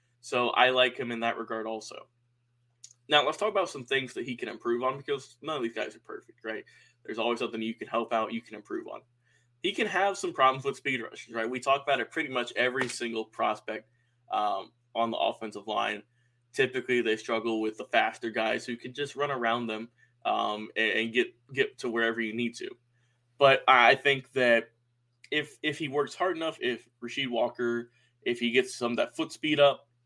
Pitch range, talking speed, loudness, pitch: 115-135 Hz, 210 wpm, -29 LUFS, 120 Hz